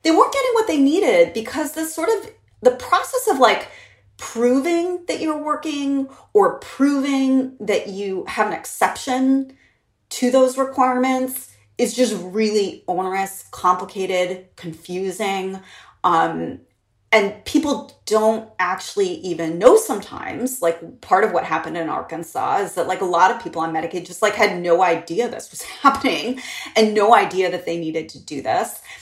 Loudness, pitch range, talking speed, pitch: -20 LUFS, 185-285 Hz, 155 wpm, 240 Hz